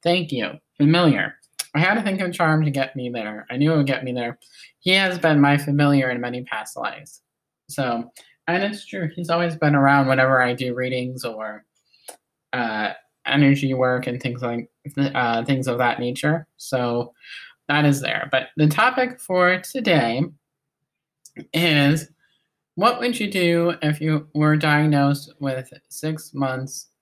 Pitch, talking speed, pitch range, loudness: 145 Hz, 165 wpm, 130-160 Hz, -21 LUFS